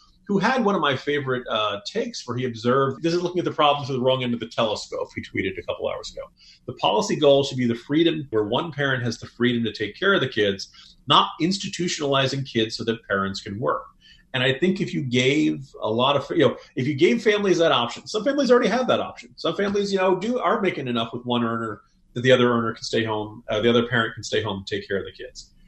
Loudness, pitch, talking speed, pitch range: -23 LUFS, 140 Hz, 260 wpm, 120-190 Hz